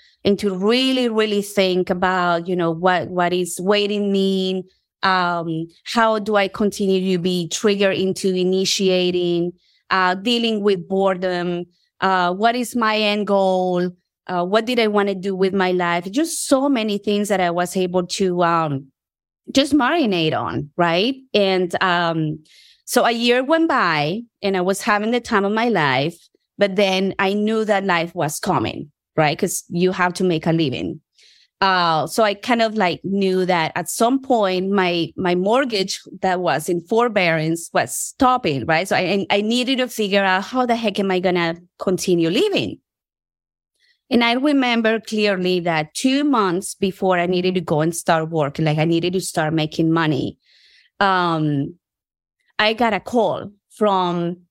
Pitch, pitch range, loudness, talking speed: 190 Hz, 175-215 Hz, -19 LUFS, 170 wpm